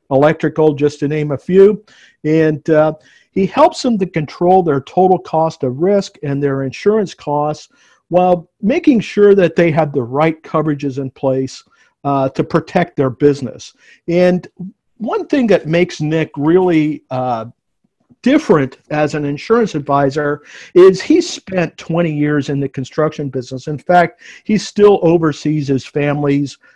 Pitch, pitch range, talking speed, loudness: 155 Hz, 145-185 Hz, 150 wpm, -15 LUFS